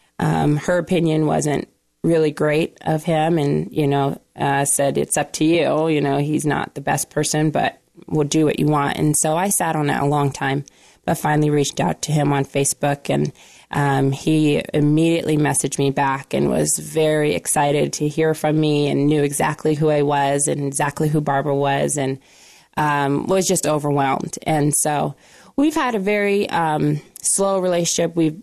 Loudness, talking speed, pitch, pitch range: -19 LUFS, 185 wpm, 150 Hz, 140-155 Hz